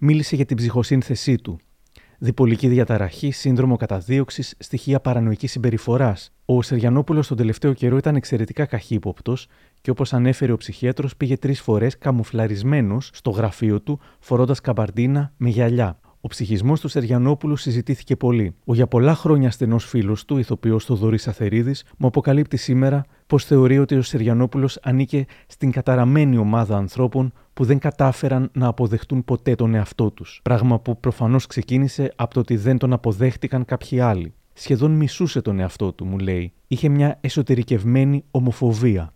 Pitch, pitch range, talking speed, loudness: 125 Hz, 115-135 Hz, 150 wpm, -20 LUFS